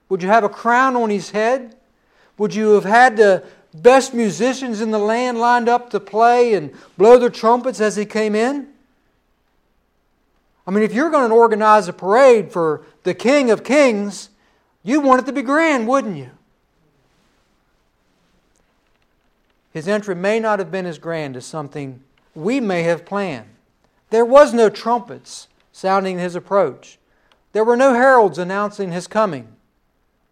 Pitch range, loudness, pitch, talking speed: 190-245 Hz, -16 LUFS, 215 Hz, 160 wpm